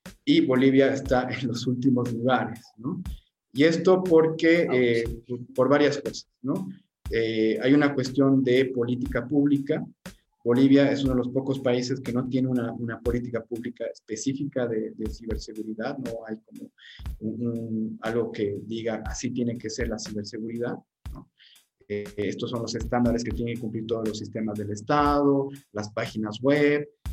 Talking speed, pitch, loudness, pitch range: 160 wpm, 120 Hz, -26 LUFS, 110-135 Hz